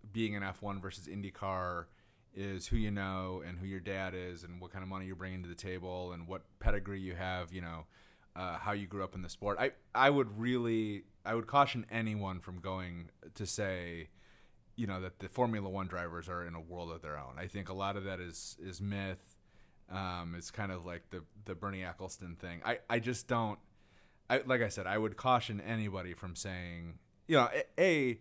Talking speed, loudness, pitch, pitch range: 215 wpm, -37 LUFS, 95 Hz, 90-105 Hz